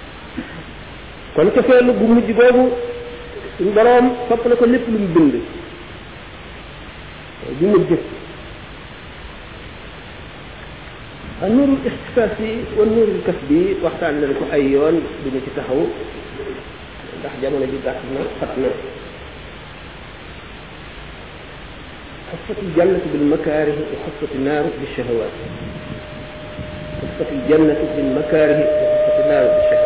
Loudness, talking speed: -17 LUFS, 50 wpm